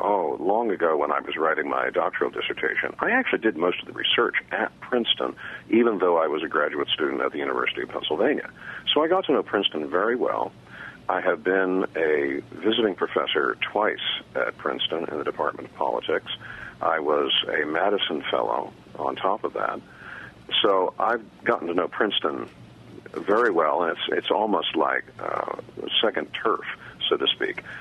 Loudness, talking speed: -24 LUFS, 175 wpm